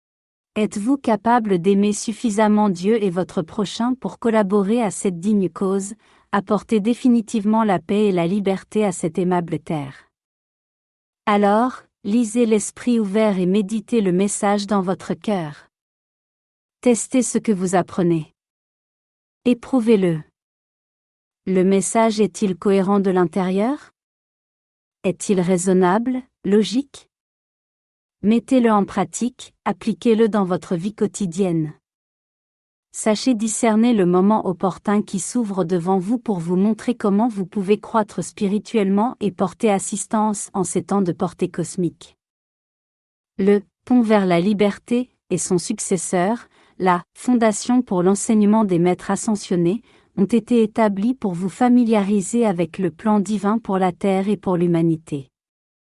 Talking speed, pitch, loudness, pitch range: 125 wpm, 205 Hz, -20 LUFS, 185-225 Hz